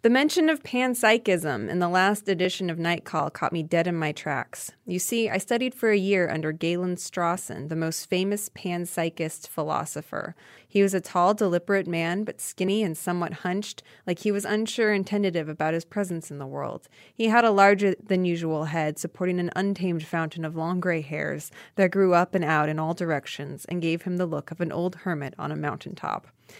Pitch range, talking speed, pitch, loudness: 165-200 Hz, 200 wpm, 180 Hz, -26 LUFS